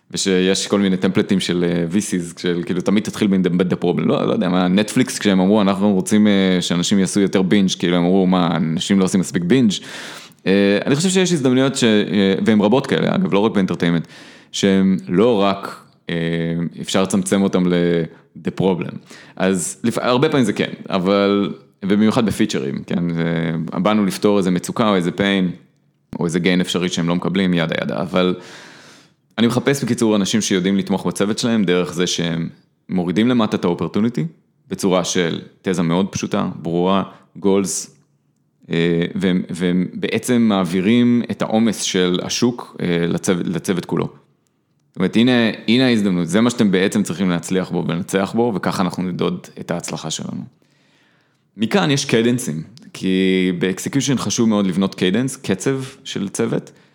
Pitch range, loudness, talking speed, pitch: 90-110 Hz, -18 LUFS, 160 wpm, 95 Hz